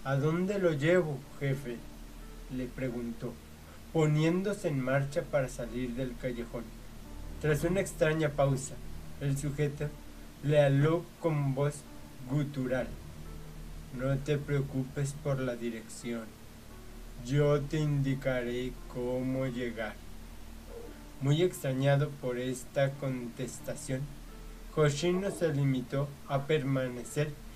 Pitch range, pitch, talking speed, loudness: 115-145 Hz, 130 Hz, 100 wpm, -32 LUFS